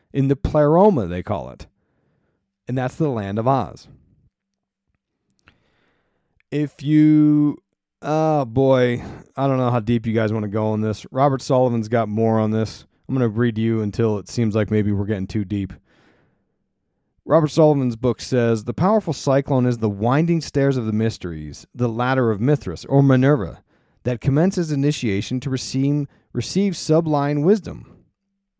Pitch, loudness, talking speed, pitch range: 125 Hz, -20 LUFS, 160 wpm, 110-145 Hz